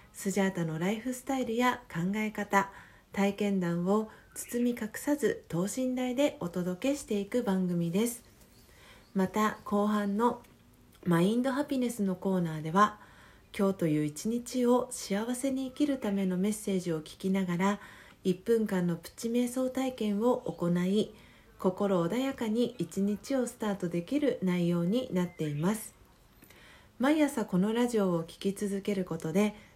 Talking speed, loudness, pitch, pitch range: 285 characters per minute, -31 LUFS, 205 Hz, 185-240 Hz